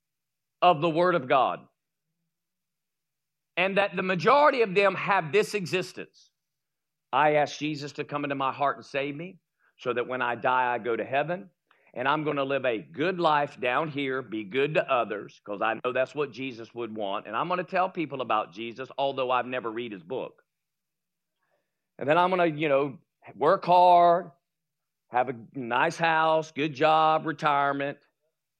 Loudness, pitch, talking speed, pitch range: -26 LUFS, 150 Hz, 180 wpm, 135-170 Hz